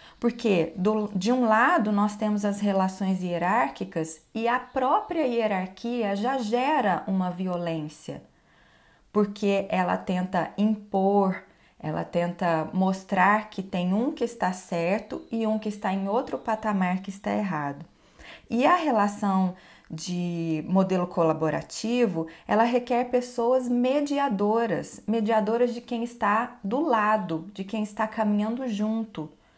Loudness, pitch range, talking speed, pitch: -26 LUFS, 185-230 Hz, 125 wpm, 205 Hz